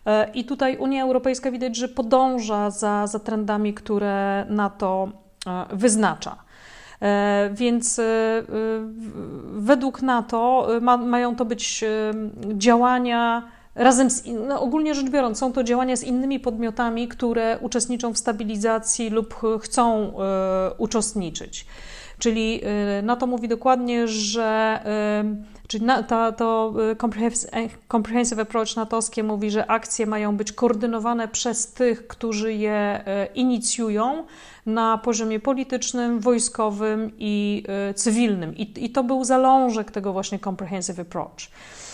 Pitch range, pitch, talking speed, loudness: 215-245 Hz, 225 Hz, 115 wpm, -22 LUFS